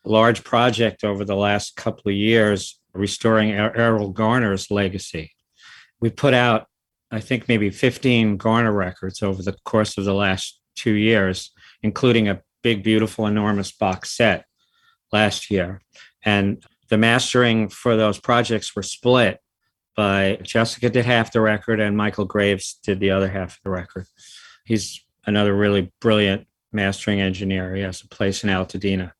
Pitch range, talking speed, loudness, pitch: 95-115 Hz, 155 wpm, -20 LUFS, 105 Hz